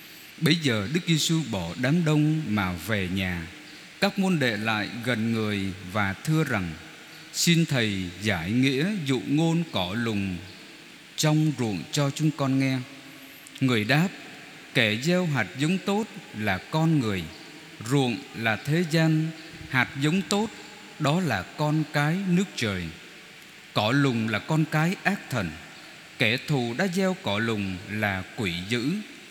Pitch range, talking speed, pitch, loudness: 110-160 Hz, 145 wpm, 140 Hz, -26 LUFS